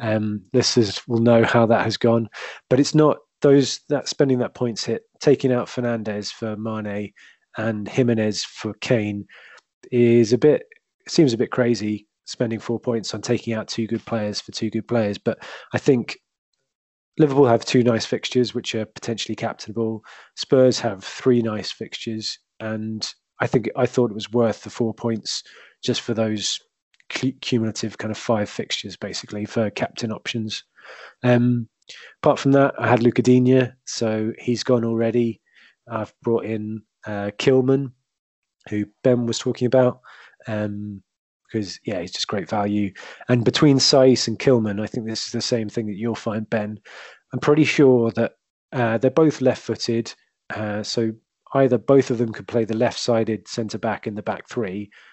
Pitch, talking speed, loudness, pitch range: 115 Hz, 170 wpm, -21 LUFS, 110-125 Hz